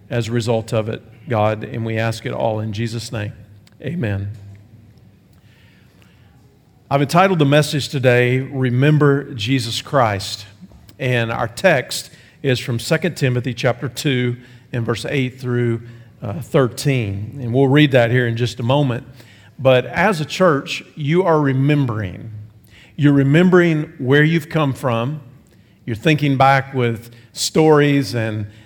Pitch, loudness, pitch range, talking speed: 125 Hz, -18 LUFS, 110-140 Hz, 140 wpm